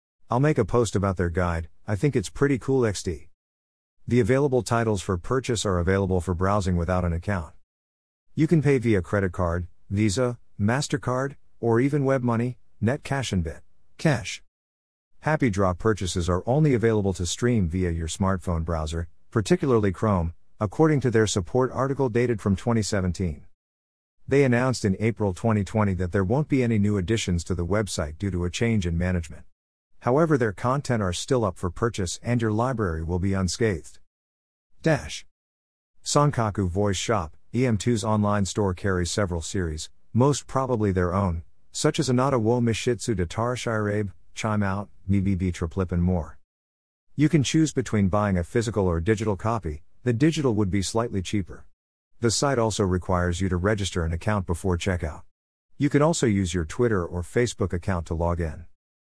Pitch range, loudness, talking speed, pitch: 90-120 Hz, -25 LUFS, 165 wpm, 100 Hz